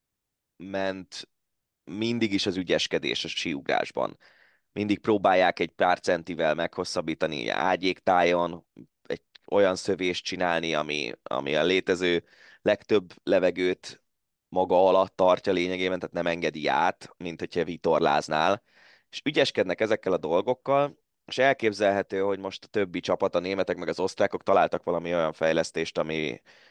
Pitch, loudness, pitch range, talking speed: 95 Hz, -26 LUFS, 85-100 Hz, 130 wpm